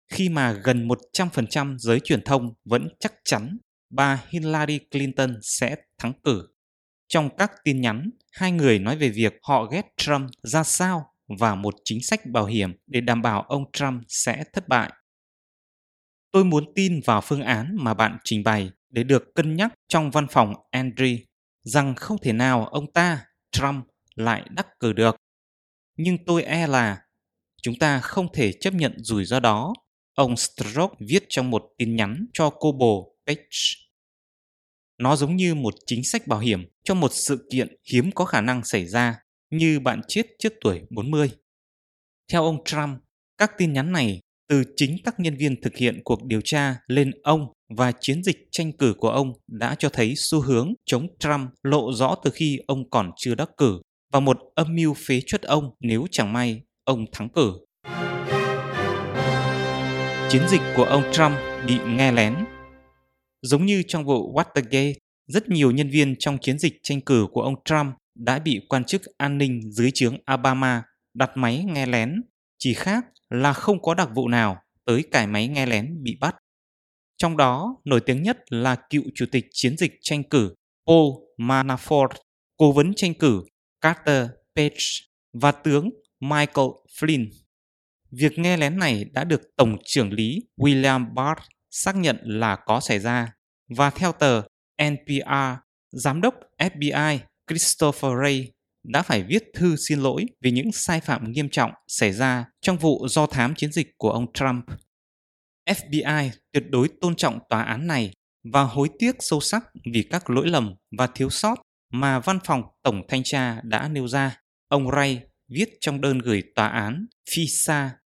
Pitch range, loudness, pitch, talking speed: 120-155 Hz, -23 LUFS, 135 Hz, 175 wpm